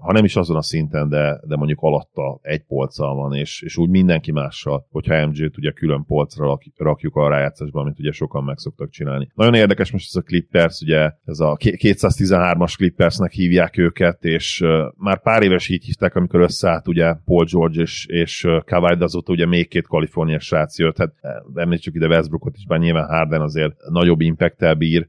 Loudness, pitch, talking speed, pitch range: -18 LUFS, 85 Hz, 190 wpm, 75-90 Hz